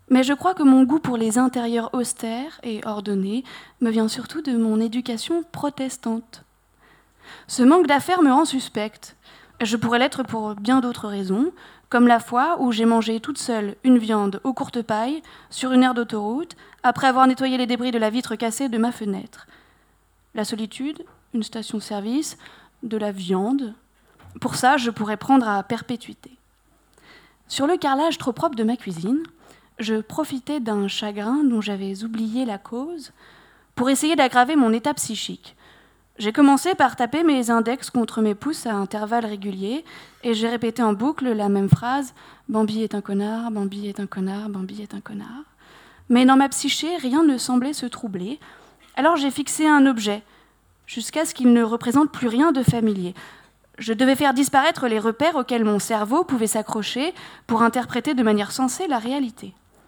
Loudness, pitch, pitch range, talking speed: -21 LUFS, 240 Hz, 220-275 Hz, 170 wpm